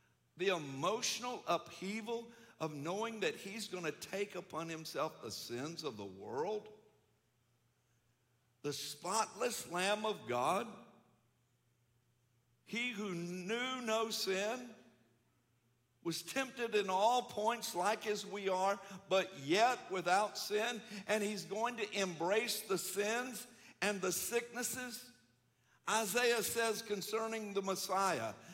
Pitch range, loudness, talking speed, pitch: 160-225 Hz, -38 LUFS, 115 wpm, 200 Hz